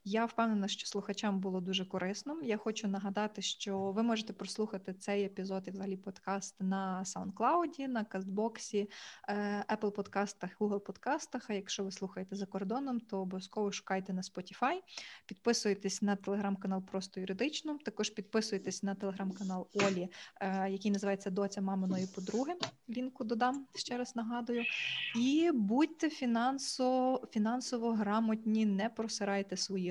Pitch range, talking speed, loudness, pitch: 195-235 Hz, 130 wpm, -36 LUFS, 205 Hz